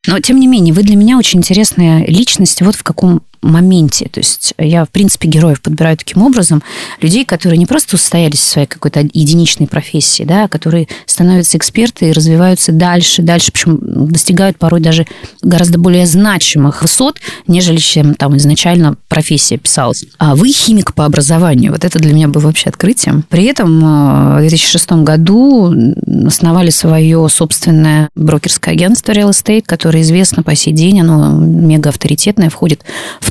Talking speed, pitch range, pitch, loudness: 160 wpm, 155-185 Hz, 165 Hz, -8 LUFS